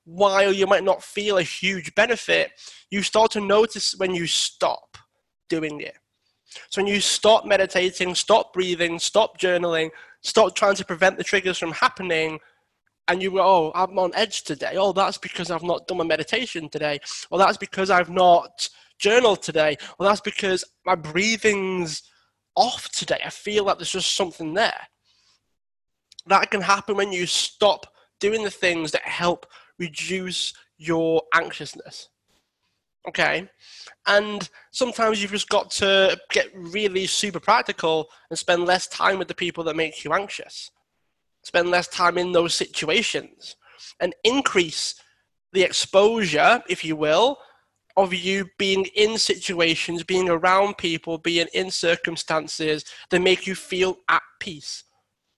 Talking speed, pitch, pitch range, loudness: 150 wpm, 185 Hz, 170-200 Hz, -22 LUFS